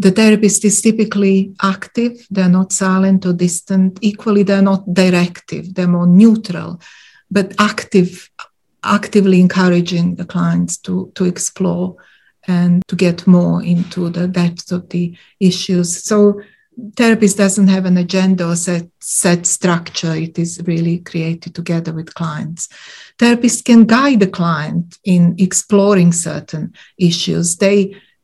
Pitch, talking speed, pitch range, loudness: 185 Hz, 135 wpm, 175-200 Hz, -14 LUFS